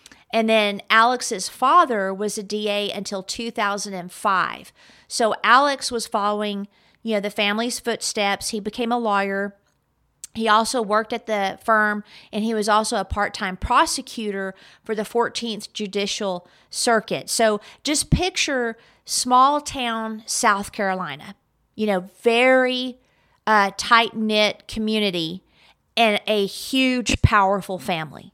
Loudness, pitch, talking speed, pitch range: -21 LUFS, 215 Hz, 125 wpm, 200-235 Hz